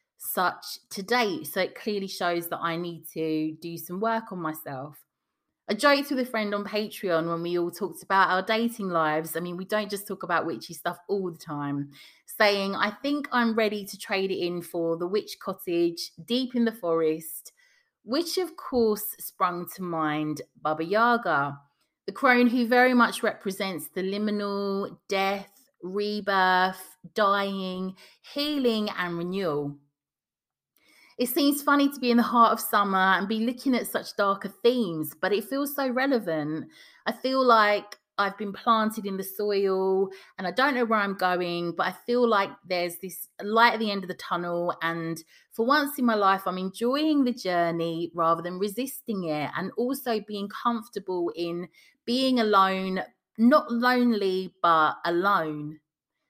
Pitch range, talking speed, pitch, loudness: 175-230 Hz, 170 wpm, 195 Hz, -26 LUFS